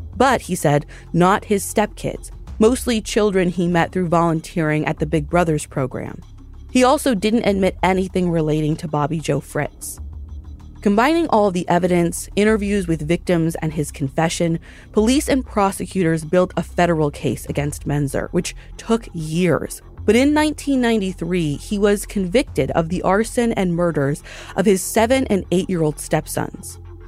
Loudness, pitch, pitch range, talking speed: -19 LUFS, 175 Hz, 160-210 Hz, 150 wpm